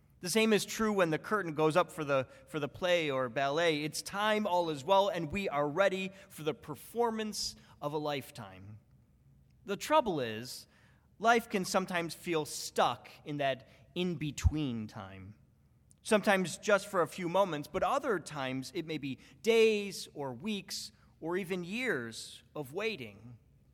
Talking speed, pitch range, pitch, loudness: 160 wpm, 140-195 Hz, 165 Hz, -33 LUFS